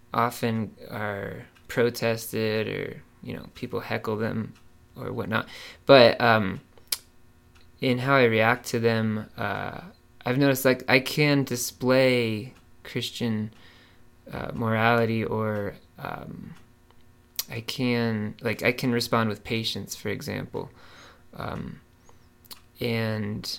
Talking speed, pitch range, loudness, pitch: 110 wpm, 110-120 Hz, -25 LUFS, 115 Hz